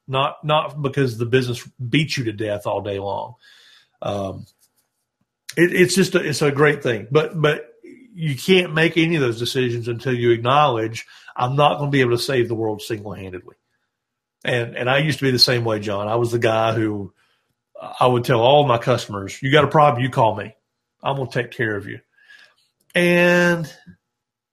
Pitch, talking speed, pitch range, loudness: 130 Hz, 195 wpm, 115-150 Hz, -19 LUFS